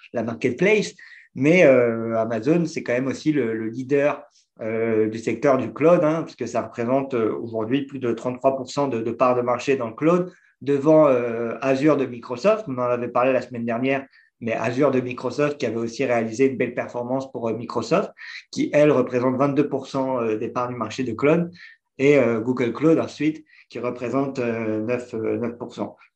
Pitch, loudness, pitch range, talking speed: 125 Hz, -22 LUFS, 120-140 Hz, 180 wpm